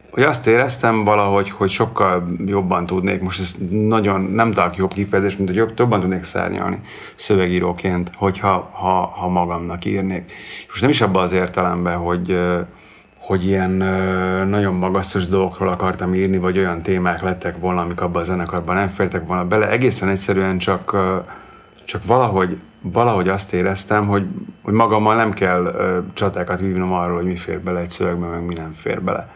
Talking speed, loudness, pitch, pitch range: 165 wpm, -18 LUFS, 95 Hz, 90-100 Hz